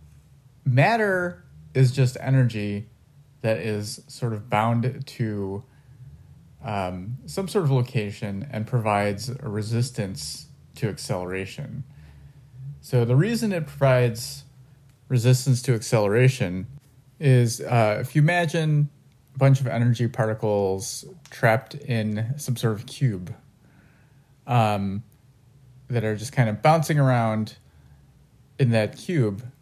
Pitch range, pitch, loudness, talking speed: 110-135 Hz, 125 Hz, -24 LUFS, 115 wpm